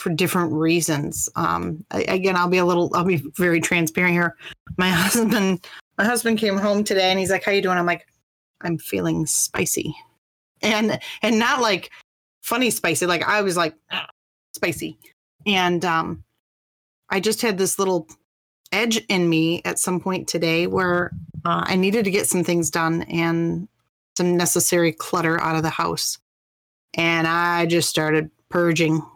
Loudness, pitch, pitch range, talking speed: -21 LUFS, 175 Hz, 165-190 Hz, 165 wpm